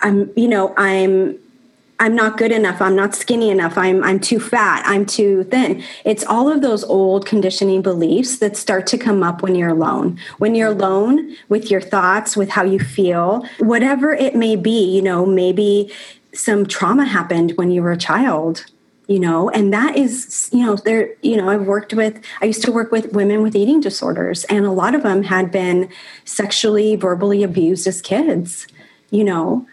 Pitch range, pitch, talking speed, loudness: 190-225 Hz, 205 Hz, 190 wpm, -16 LUFS